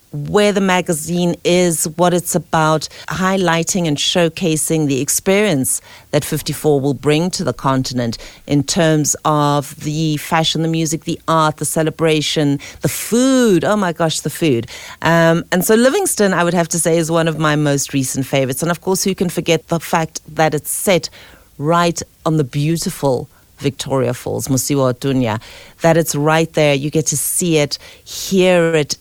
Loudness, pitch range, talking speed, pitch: -16 LUFS, 145-175 Hz, 170 wpm, 160 Hz